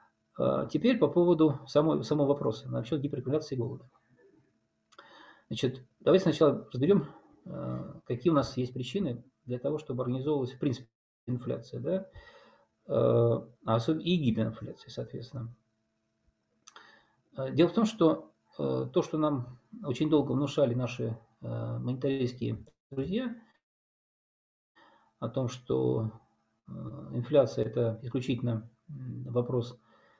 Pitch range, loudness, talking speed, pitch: 115-150 Hz, -30 LUFS, 100 wpm, 125 Hz